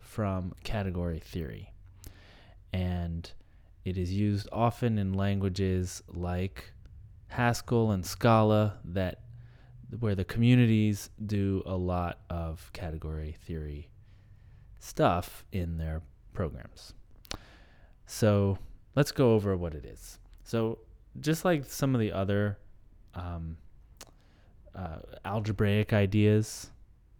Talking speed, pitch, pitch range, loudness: 100 wpm, 100 Hz, 90-110 Hz, -30 LUFS